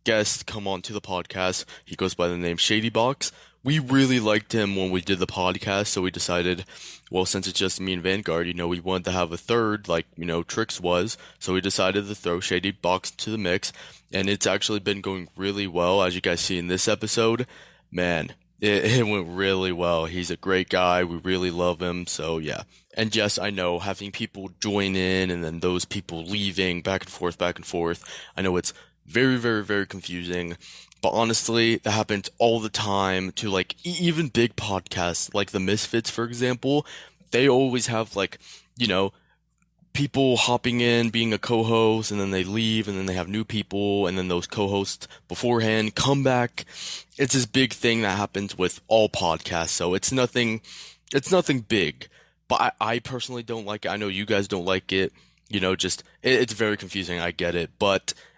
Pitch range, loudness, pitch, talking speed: 90-115 Hz, -24 LUFS, 100 Hz, 200 wpm